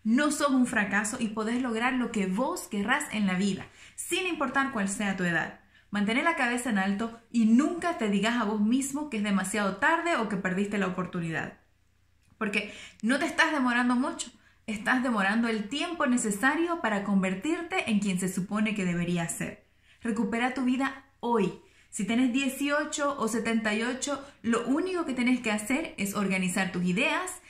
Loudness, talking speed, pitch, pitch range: -28 LUFS, 175 wpm, 230 Hz, 200-270 Hz